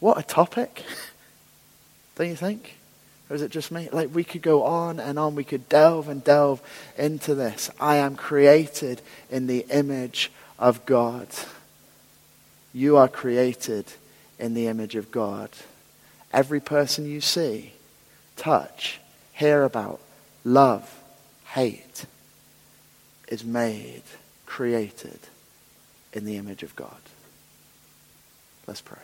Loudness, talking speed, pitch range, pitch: -23 LUFS, 125 wpm, 120-150 Hz, 140 Hz